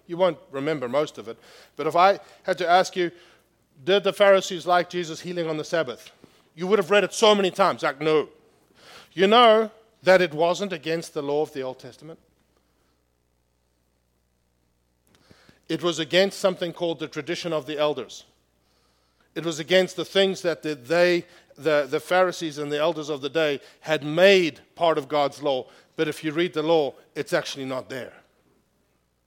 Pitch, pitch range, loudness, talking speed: 160 Hz, 140-180 Hz, -23 LUFS, 175 wpm